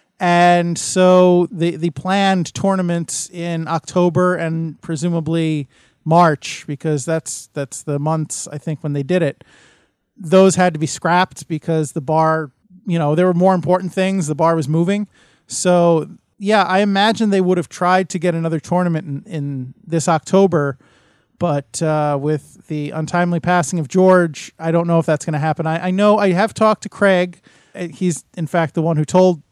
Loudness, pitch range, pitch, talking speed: -17 LUFS, 155-185 Hz, 170 Hz, 180 wpm